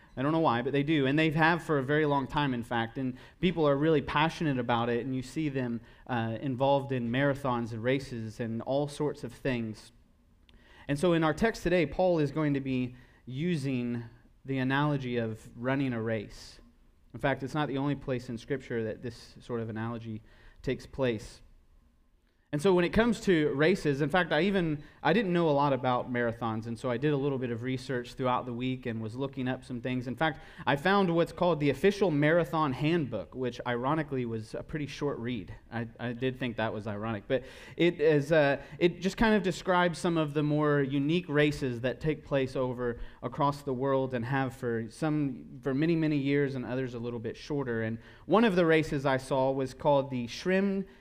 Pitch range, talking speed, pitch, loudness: 120-150 Hz, 210 wpm, 135 Hz, -30 LUFS